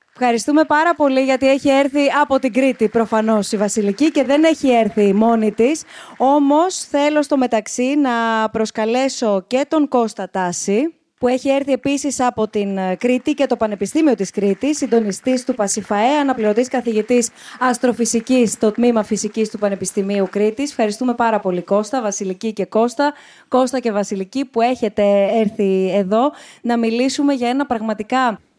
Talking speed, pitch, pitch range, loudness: 150 wpm, 235 Hz, 215-270 Hz, -17 LUFS